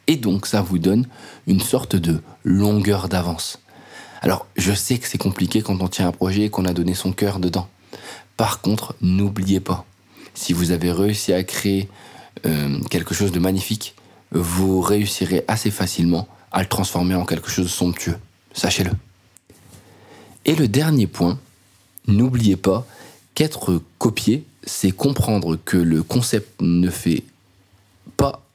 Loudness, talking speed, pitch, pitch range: -20 LUFS, 150 wpm, 95 Hz, 90-105 Hz